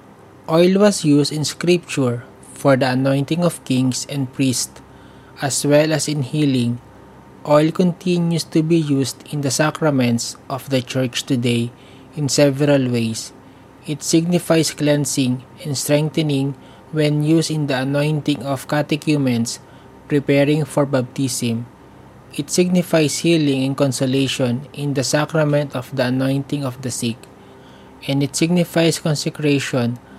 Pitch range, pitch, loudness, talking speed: 130-155 Hz, 140 Hz, -18 LUFS, 130 wpm